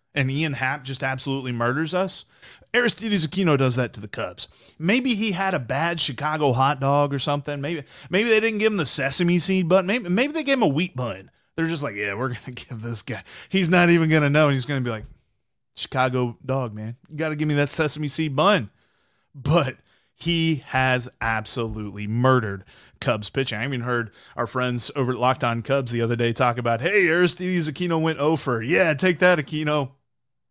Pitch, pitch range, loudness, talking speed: 140 Hz, 125-170 Hz, -22 LUFS, 210 wpm